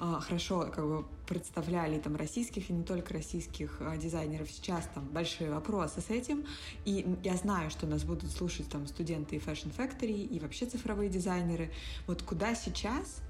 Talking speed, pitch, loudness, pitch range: 160 wpm, 175 Hz, -37 LUFS, 155-200 Hz